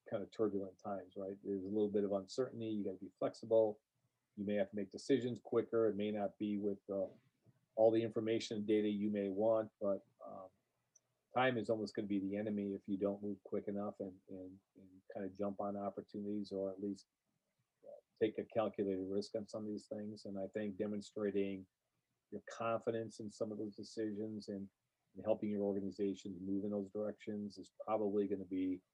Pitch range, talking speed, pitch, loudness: 100-110 Hz, 205 wpm, 105 Hz, -41 LUFS